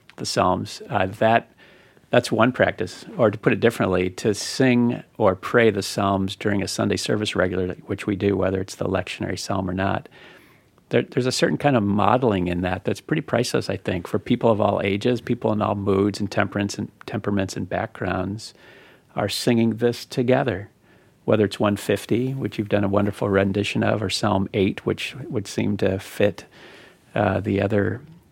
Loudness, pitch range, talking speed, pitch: -22 LUFS, 100-115 Hz, 180 wpm, 105 Hz